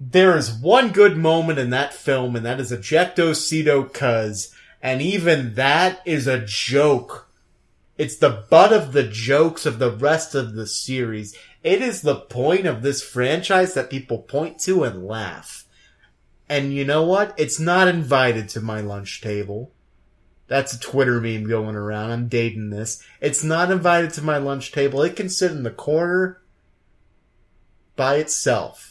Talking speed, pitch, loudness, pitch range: 165 wpm, 135 Hz, -20 LUFS, 115-160 Hz